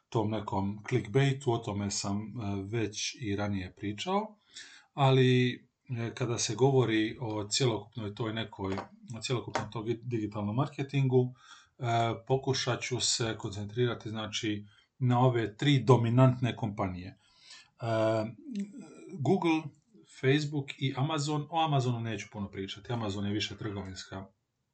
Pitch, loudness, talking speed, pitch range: 115 Hz, -31 LUFS, 110 wpm, 105-130 Hz